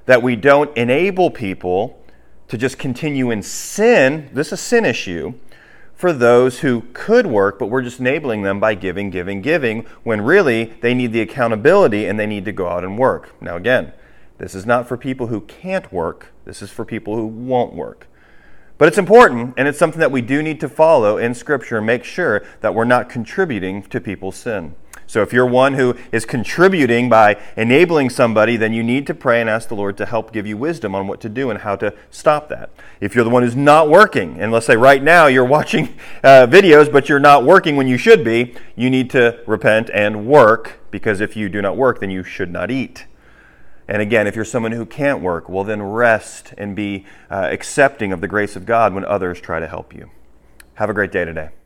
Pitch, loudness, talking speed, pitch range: 120 Hz, -15 LUFS, 220 wpm, 105-135 Hz